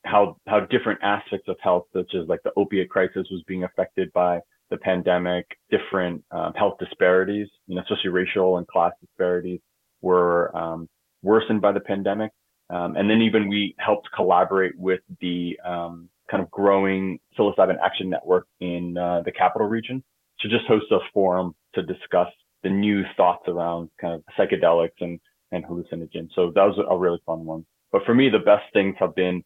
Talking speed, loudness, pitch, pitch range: 180 wpm, -23 LUFS, 90 Hz, 85-100 Hz